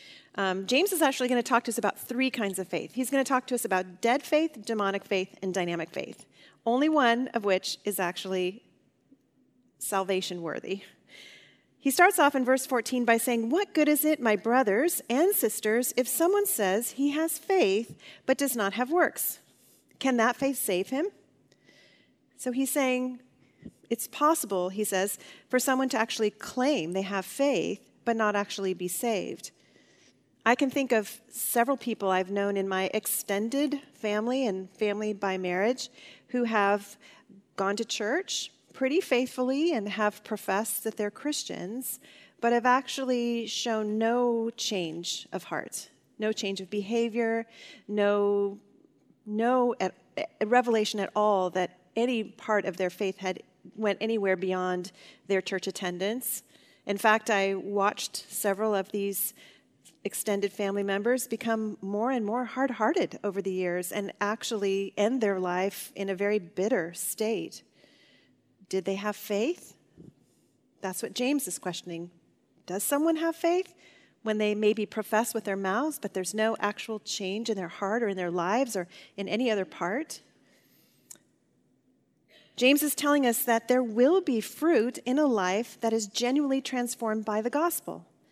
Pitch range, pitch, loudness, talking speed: 195-255 Hz, 220 Hz, -28 LUFS, 160 wpm